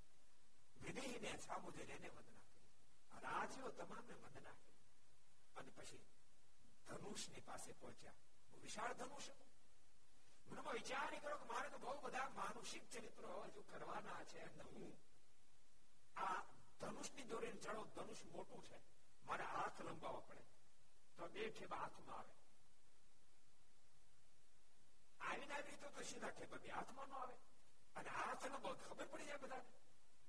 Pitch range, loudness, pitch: 230-285 Hz, -53 LUFS, 260 Hz